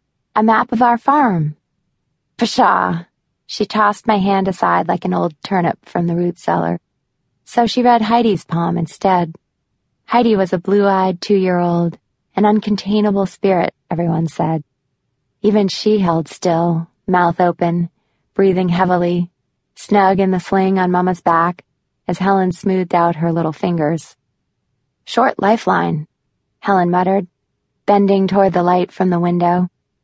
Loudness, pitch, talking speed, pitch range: -16 LUFS, 180 Hz, 135 wpm, 170-200 Hz